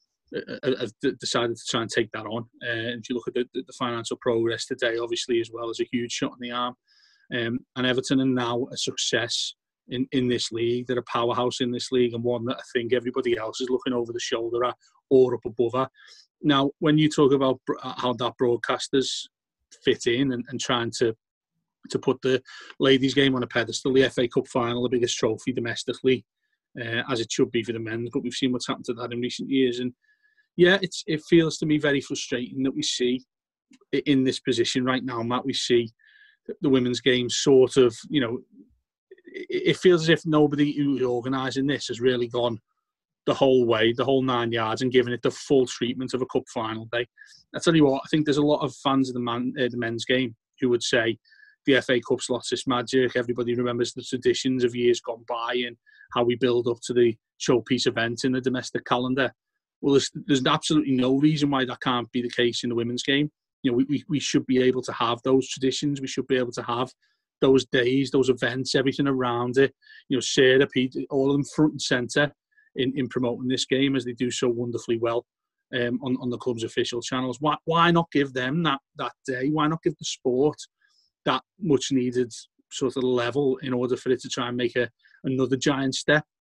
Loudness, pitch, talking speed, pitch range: -25 LUFS, 130 Hz, 220 wpm, 120-140 Hz